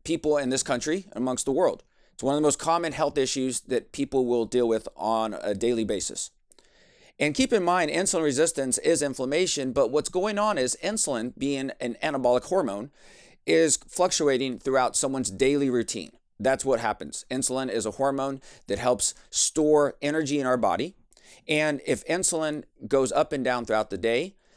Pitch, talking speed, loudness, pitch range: 135 Hz, 175 wpm, -26 LUFS, 125-155 Hz